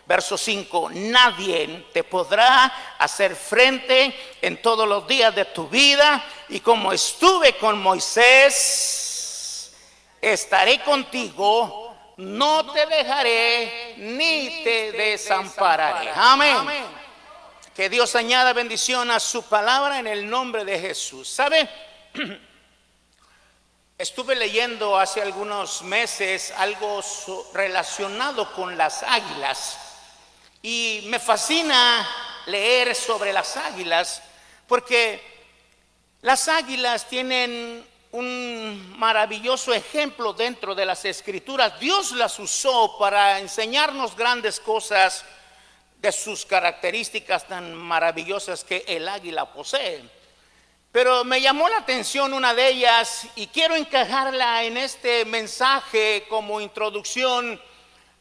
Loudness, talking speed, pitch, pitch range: -20 LUFS, 105 wpm, 230 Hz, 200-255 Hz